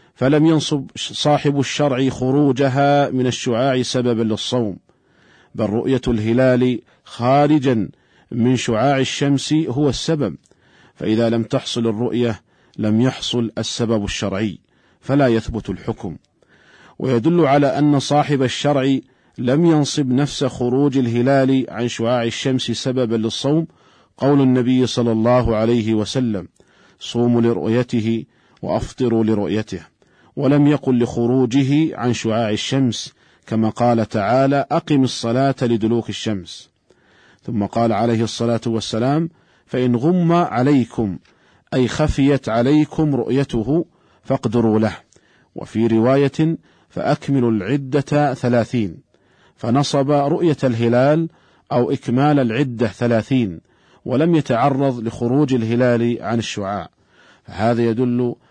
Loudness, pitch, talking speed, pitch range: -18 LUFS, 125 Hz, 105 wpm, 115-140 Hz